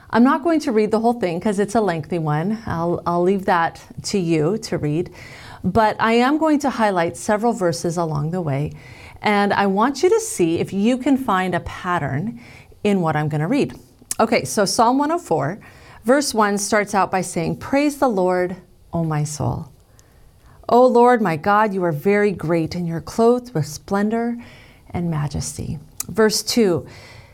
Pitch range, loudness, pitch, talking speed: 155-220 Hz, -19 LUFS, 185 Hz, 180 wpm